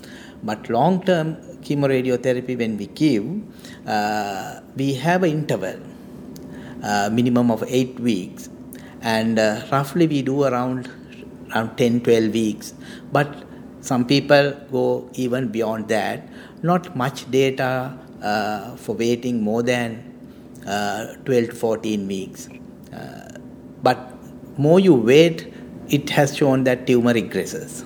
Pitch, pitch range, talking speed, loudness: 125 Hz, 115-140 Hz, 125 wpm, -21 LUFS